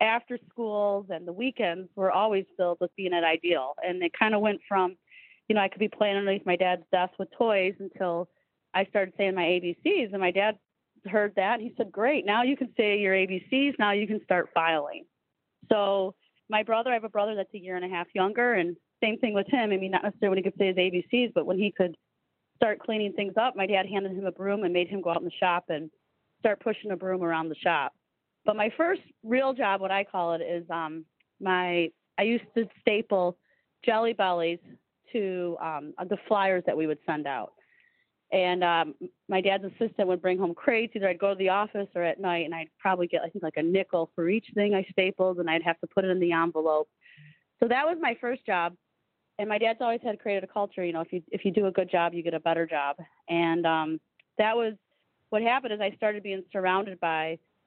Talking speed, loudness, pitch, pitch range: 235 wpm, -28 LUFS, 195 Hz, 175-215 Hz